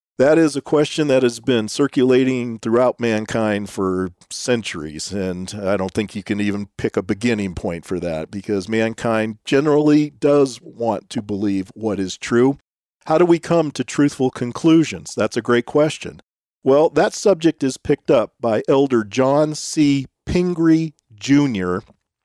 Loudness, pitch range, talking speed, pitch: -19 LUFS, 105-145 Hz, 155 wpm, 120 Hz